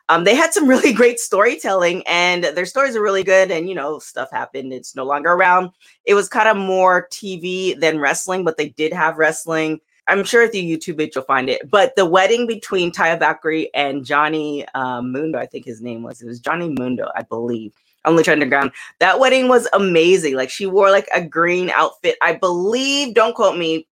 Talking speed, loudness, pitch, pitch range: 210 wpm, -16 LUFS, 175 Hz, 155-195 Hz